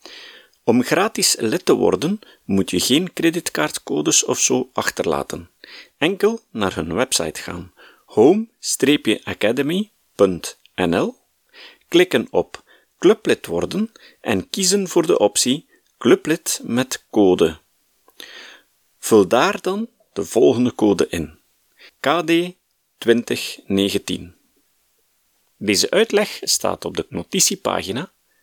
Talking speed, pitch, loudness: 95 wpm, 205 Hz, -19 LUFS